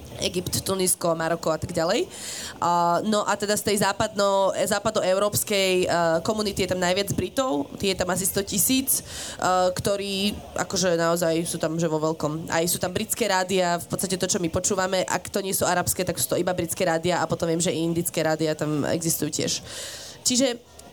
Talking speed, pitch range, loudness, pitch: 190 wpm, 165-200 Hz, -24 LUFS, 185 Hz